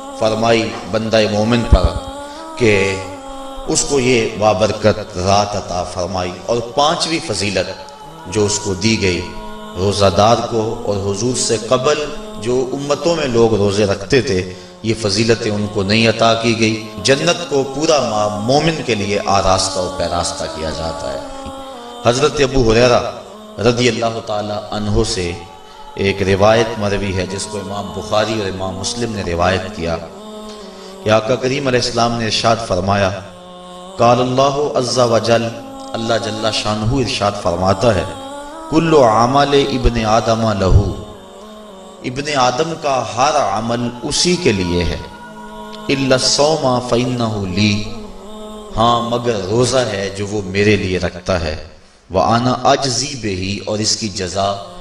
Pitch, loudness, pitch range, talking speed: 115 Hz, -16 LUFS, 100-135 Hz, 140 wpm